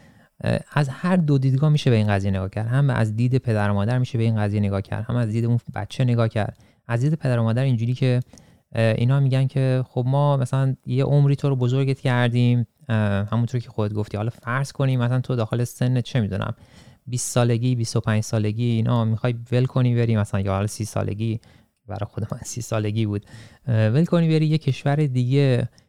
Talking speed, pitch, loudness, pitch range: 200 wpm, 120 Hz, -22 LUFS, 110-130 Hz